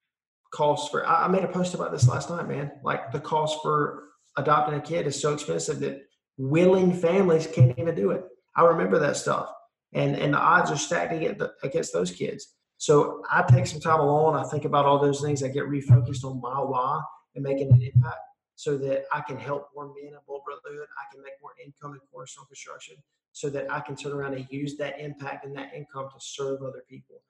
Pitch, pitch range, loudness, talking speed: 145 Hz, 135-155 Hz, -25 LUFS, 210 wpm